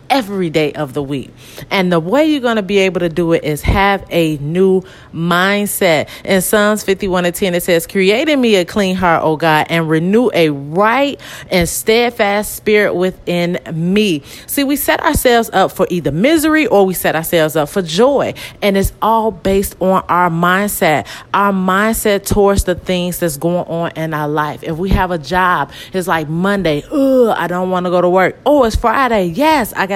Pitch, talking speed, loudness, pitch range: 185 Hz, 200 wpm, -14 LUFS, 170-210 Hz